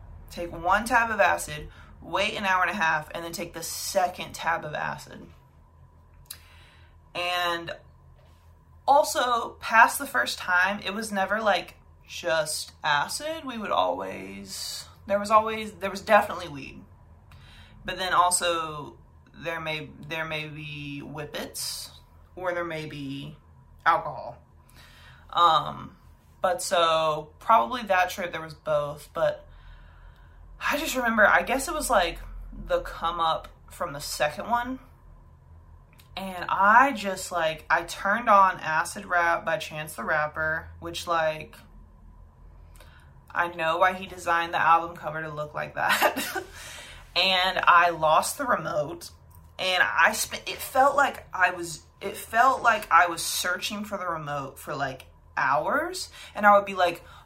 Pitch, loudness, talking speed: 165 Hz, -25 LUFS, 145 wpm